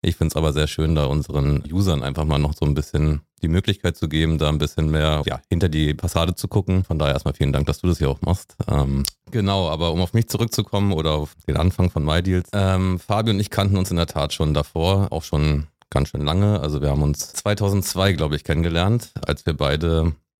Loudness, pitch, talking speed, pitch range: -21 LUFS, 80 Hz, 235 wpm, 75-95 Hz